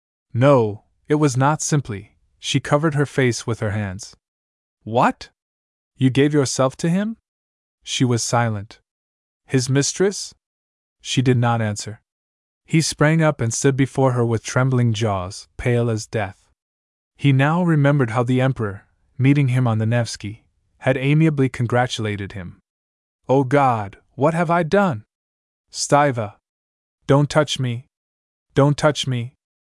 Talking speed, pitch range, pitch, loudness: 140 wpm, 90-140 Hz, 120 Hz, -19 LUFS